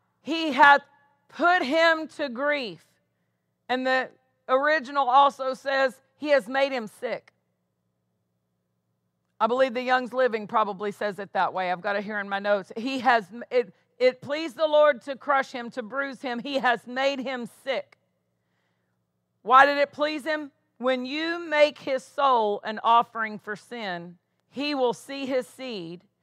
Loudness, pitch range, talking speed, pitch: -25 LUFS, 200-280 Hz, 160 wpm, 255 Hz